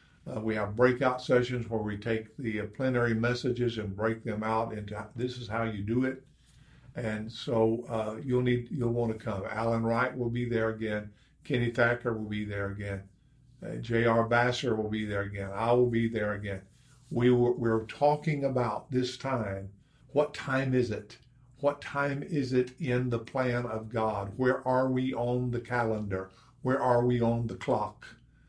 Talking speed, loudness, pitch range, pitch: 190 wpm, -30 LUFS, 110-125 Hz, 120 Hz